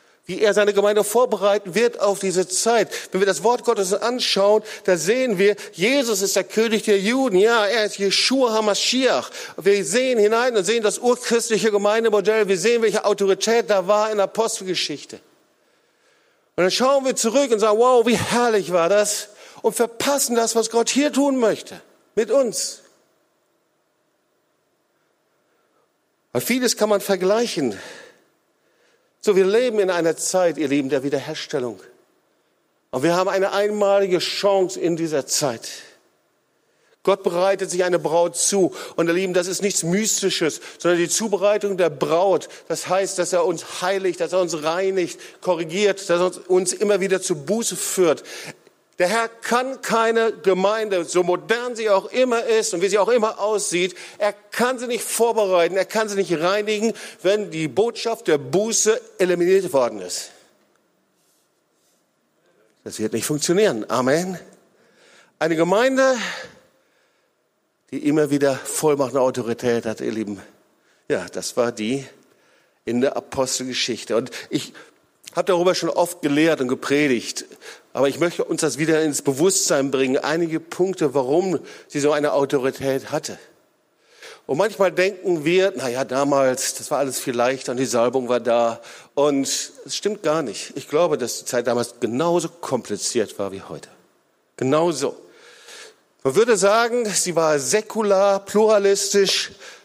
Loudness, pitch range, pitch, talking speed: -20 LUFS, 165-220 Hz, 195 Hz, 155 wpm